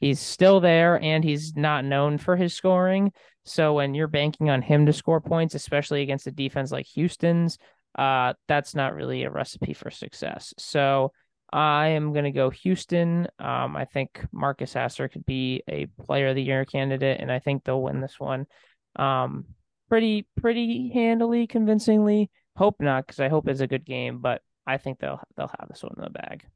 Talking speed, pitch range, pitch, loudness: 190 wpm, 135-170 Hz, 145 Hz, -24 LUFS